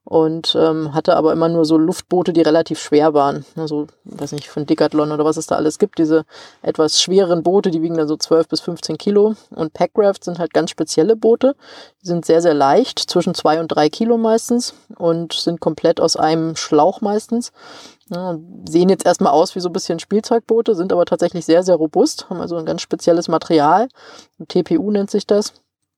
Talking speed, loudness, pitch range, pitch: 200 wpm, -16 LUFS, 160-200 Hz, 170 Hz